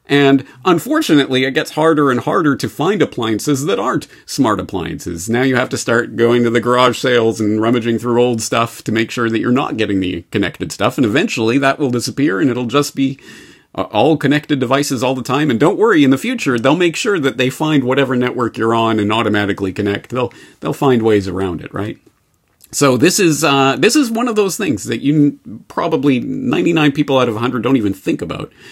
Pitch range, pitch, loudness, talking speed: 115-145 Hz, 125 Hz, -15 LUFS, 215 wpm